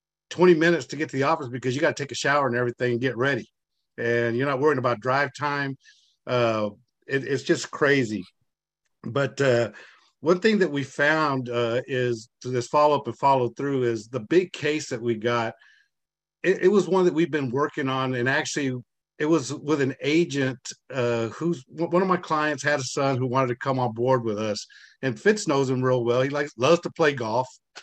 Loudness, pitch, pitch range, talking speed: -24 LUFS, 135 Hz, 125-155 Hz, 210 wpm